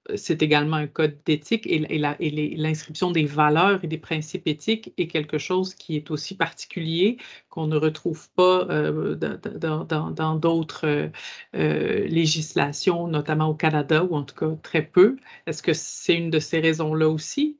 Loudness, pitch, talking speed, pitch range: -24 LUFS, 155 Hz, 150 wpm, 155-170 Hz